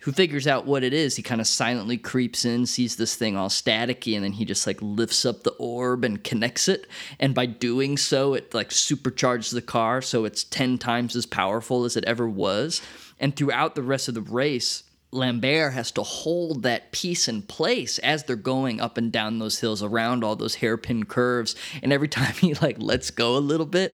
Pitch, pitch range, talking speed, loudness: 125 Hz, 115-140 Hz, 215 wpm, -24 LUFS